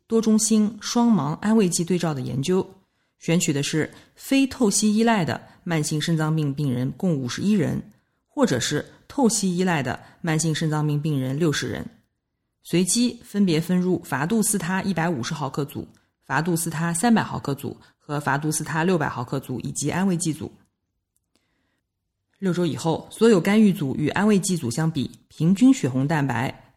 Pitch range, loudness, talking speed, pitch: 140-190 Hz, -23 LUFS, 260 characters per minute, 165 Hz